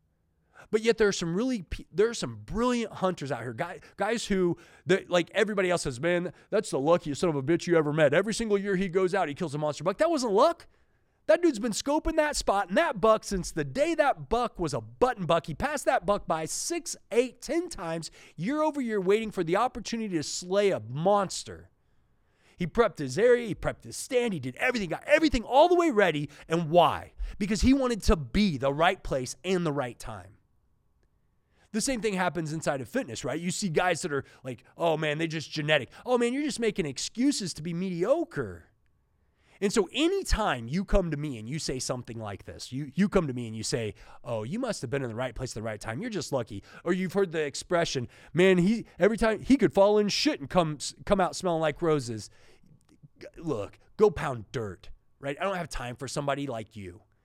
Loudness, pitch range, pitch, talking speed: -28 LUFS, 140-215 Hz, 175 Hz, 225 wpm